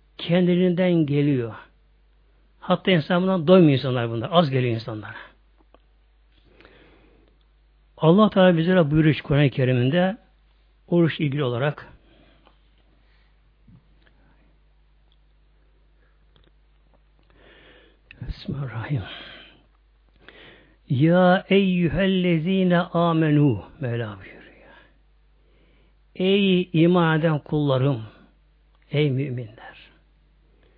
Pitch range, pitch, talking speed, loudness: 120-180 Hz, 150 Hz, 60 wpm, -21 LUFS